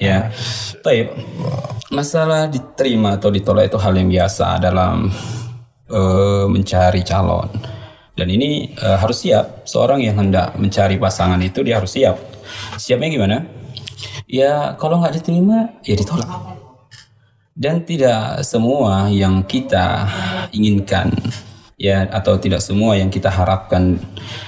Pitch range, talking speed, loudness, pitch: 95-125 Hz, 120 wpm, -17 LUFS, 105 Hz